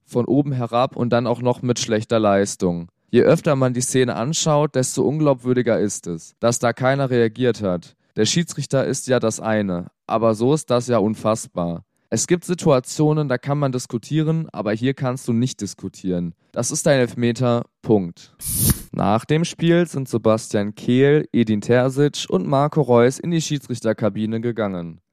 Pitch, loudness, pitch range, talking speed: 120 Hz, -20 LUFS, 110-140 Hz, 165 wpm